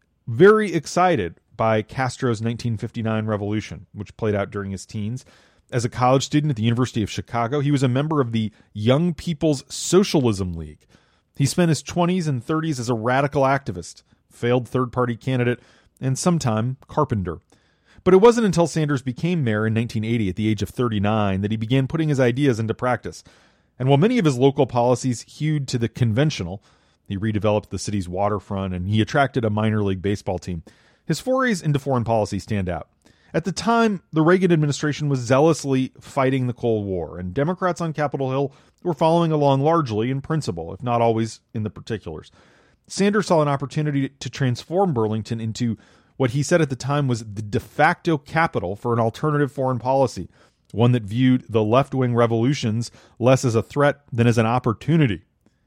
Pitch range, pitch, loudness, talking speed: 110-145 Hz, 125 Hz, -21 LUFS, 180 wpm